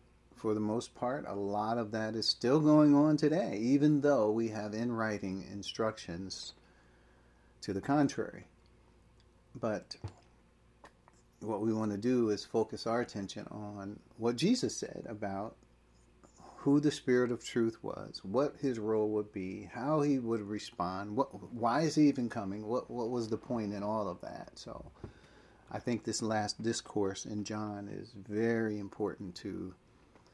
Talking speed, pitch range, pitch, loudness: 160 wpm, 100-120 Hz, 110 Hz, -34 LUFS